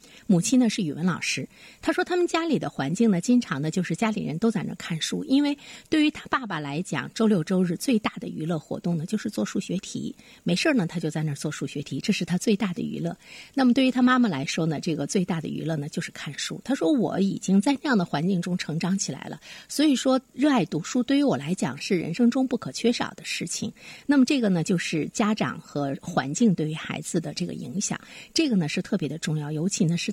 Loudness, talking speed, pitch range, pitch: -25 LUFS, 345 characters per minute, 165-245 Hz, 200 Hz